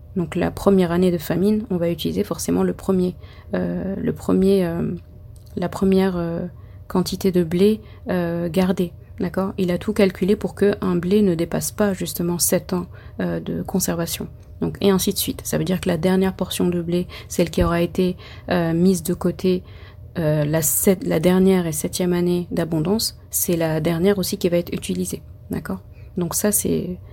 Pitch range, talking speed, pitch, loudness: 170-190 Hz, 190 wpm, 180 Hz, -21 LUFS